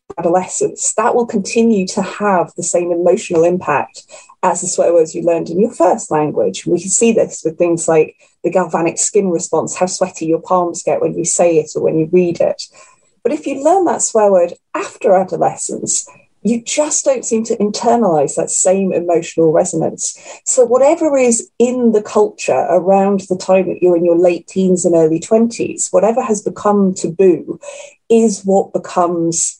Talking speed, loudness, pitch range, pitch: 180 wpm, -14 LUFS, 175-235 Hz, 195 Hz